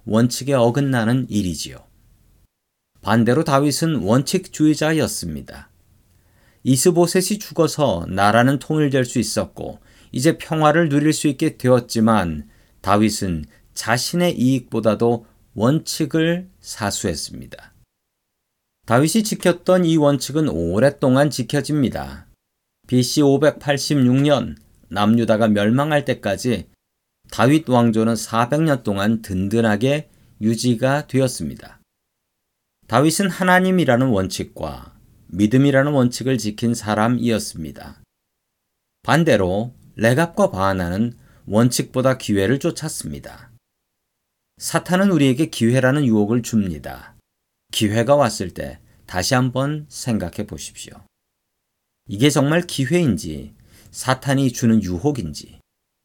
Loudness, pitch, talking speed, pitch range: -19 LUFS, 125 Hz, 250 characters per minute, 110-145 Hz